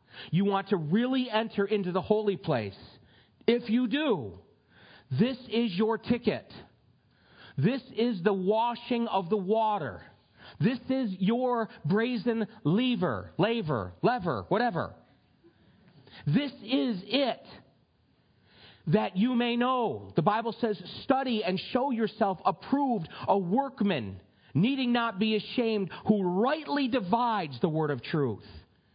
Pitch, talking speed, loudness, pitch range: 215 Hz, 120 wpm, -29 LUFS, 175-235 Hz